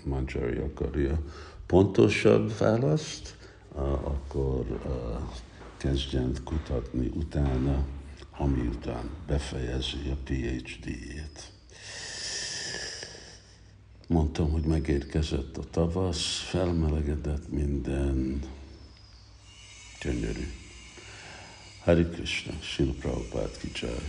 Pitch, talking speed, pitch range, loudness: 75 Hz, 65 wpm, 70-90 Hz, -30 LUFS